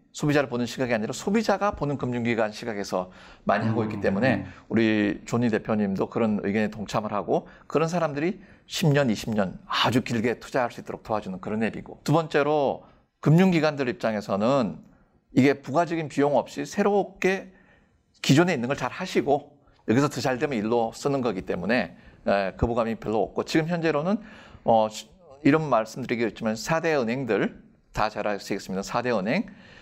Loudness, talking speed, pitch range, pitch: -25 LUFS, 355 characters per minute, 110-165 Hz, 135 Hz